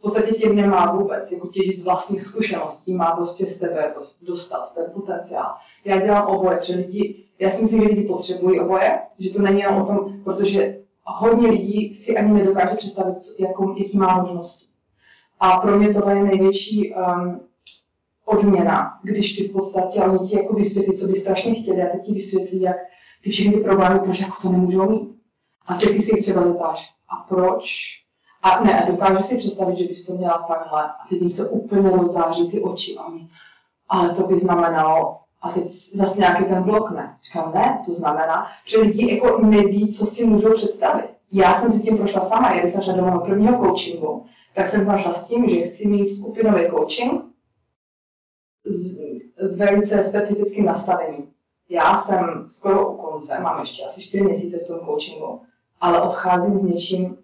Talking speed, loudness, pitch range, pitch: 185 wpm, -19 LUFS, 180-205 Hz, 190 Hz